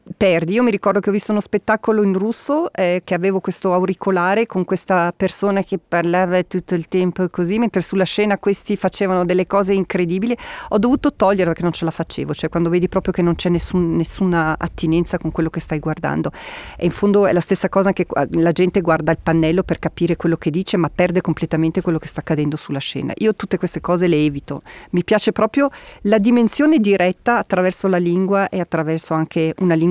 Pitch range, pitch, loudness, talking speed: 170-200 Hz, 180 Hz, -18 LUFS, 205 wpm